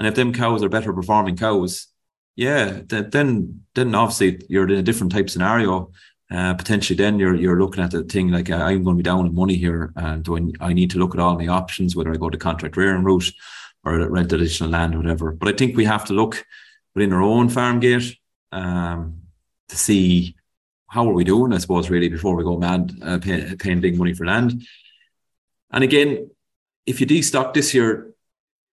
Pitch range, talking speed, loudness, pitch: 85-110 Hz, 210 wpm, -20 LUFS, 95 Hz